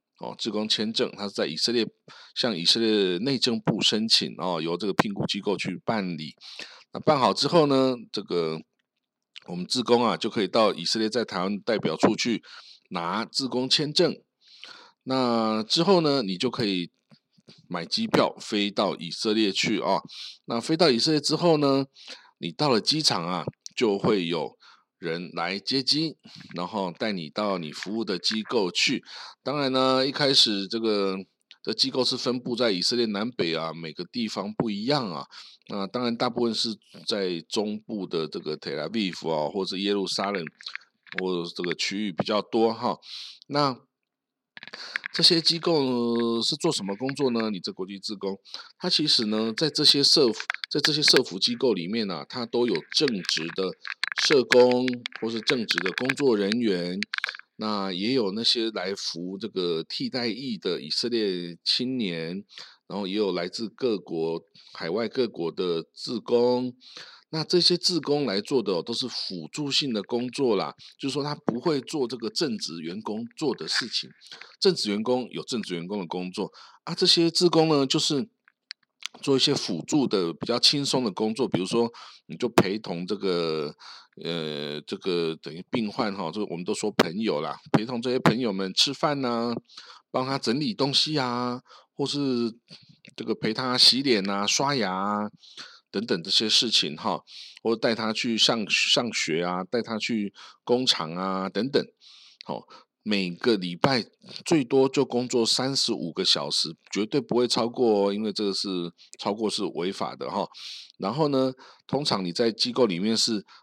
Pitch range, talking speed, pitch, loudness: 100-140 Hz, 245 characters per minute, 120 Hz, -25 LUFS